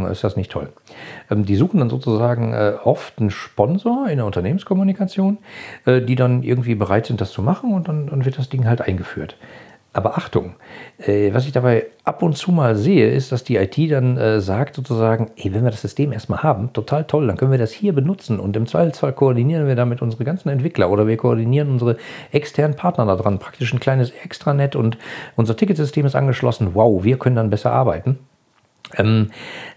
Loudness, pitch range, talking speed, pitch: -19 LUFS, 110-145 Hz, 185 wpm, 125 Hz